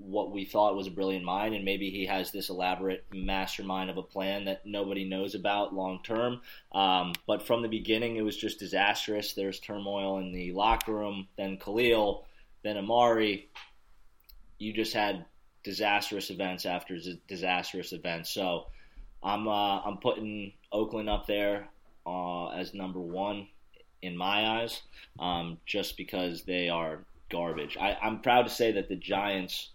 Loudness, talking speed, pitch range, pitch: -31 LUFS, 160 wpm, 95-105 Hz, 100 Hz